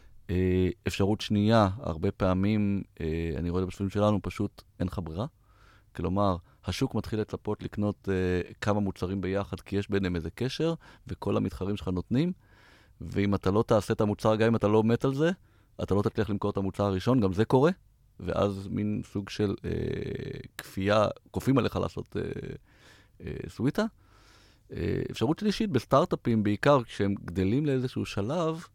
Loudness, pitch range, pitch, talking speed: -29 LUFS, 95-115 Hz, 105 Hz, 160 wpm